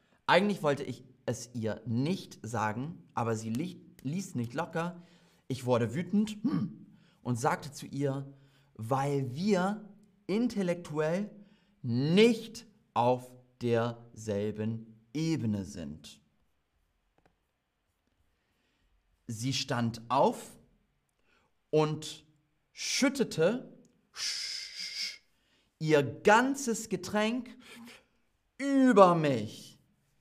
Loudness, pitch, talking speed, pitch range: -31 LUFS, 150 Hz, 75 wpm, 120-195 Hz